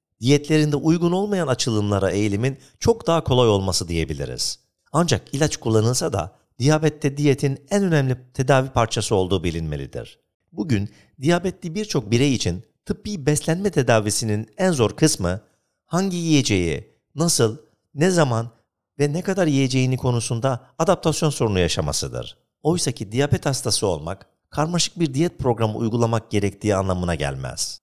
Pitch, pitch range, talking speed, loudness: 130 Hz, 105-155 Hz, 125 wpm, -21 LUFS